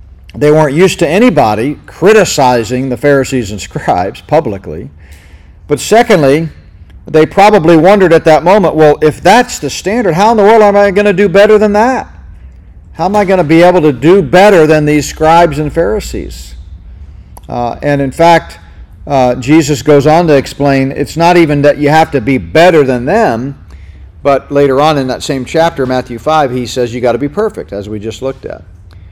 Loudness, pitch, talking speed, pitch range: -8 LUFS, 145 Hz, 190 wpm, 110-170 Hz